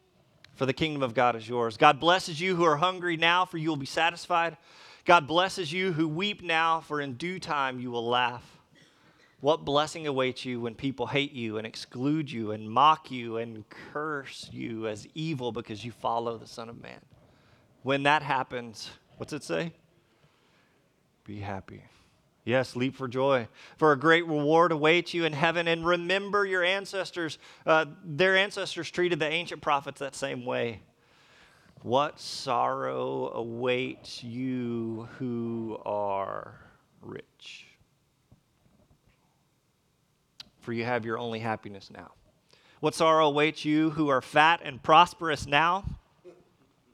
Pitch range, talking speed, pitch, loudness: 120-165 Hz, 150 wpm, 145 Hz, -27 LUFS